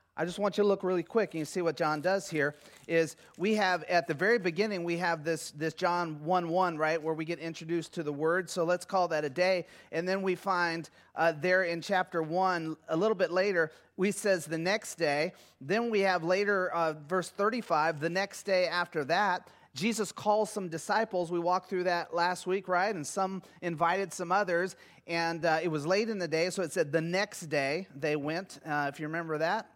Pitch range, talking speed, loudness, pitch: 165-190 Hz, 220 wpm, -31 LUFS, 175 Hz